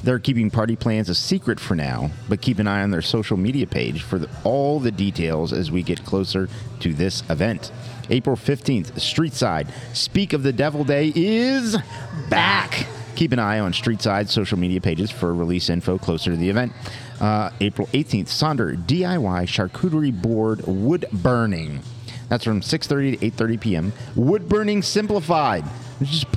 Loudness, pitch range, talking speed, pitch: -21 LUFS, 100-140 Hz, 175 wpm, 115 Hz